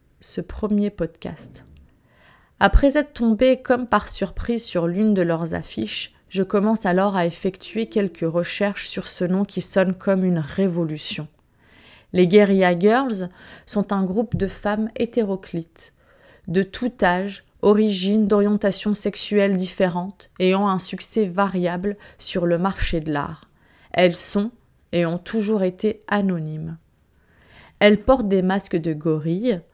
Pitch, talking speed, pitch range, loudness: 195 Hz, 135 wpm, 175-210 Hz, -21 LUFS